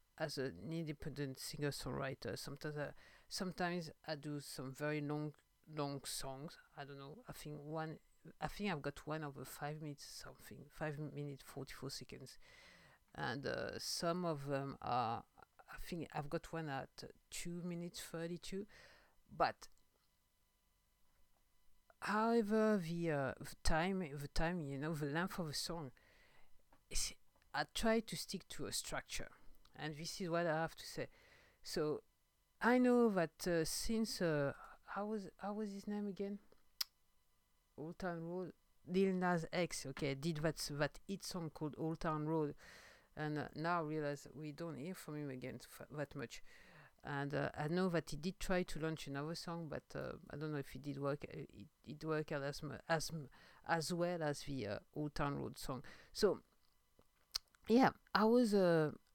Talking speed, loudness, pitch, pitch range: 165 wpm, -42 LUFS, 155 Hz, 140-175 Hz